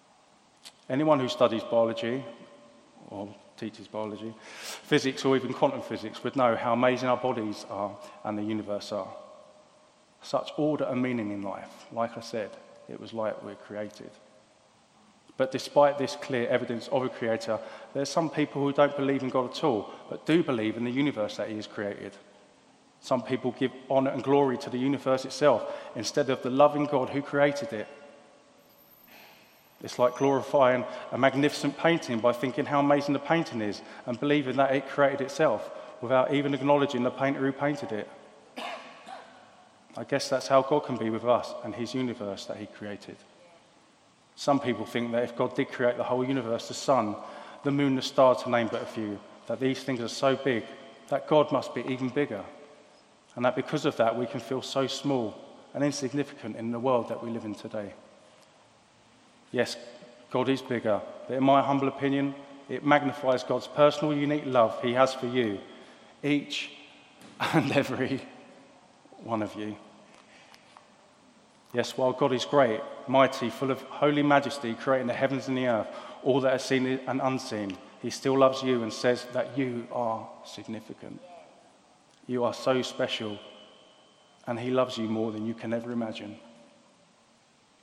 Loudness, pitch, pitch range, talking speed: -28 LUFS, 130 Hz, 115-140 Hz, 170 wpm